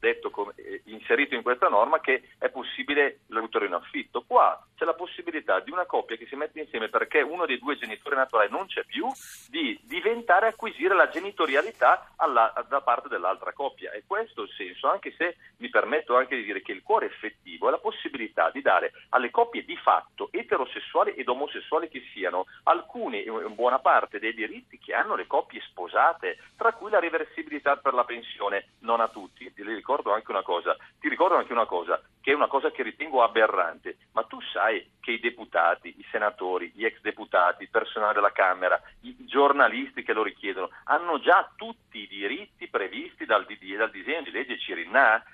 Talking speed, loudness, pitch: 185 wpm, -26 LUFS, 235 Hz